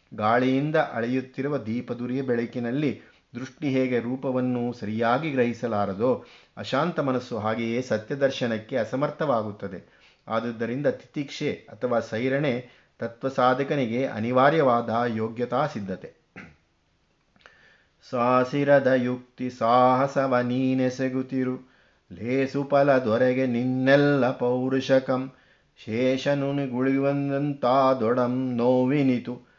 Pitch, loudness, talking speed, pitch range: 125 Hz, -25 LUFS, 70 wpm, 120-135 Hz